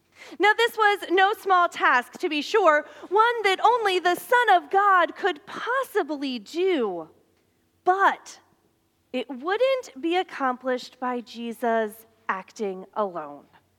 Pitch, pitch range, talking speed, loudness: 340 Hz, 250-395 Hz, 120 wpm, -23 LUFS